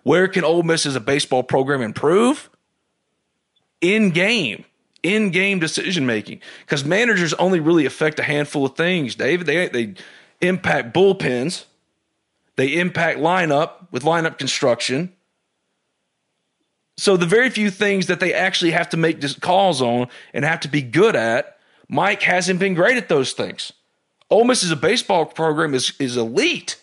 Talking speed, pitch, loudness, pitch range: 155 wpm, 170 Hz, -18 LUFS, 145-185 Hz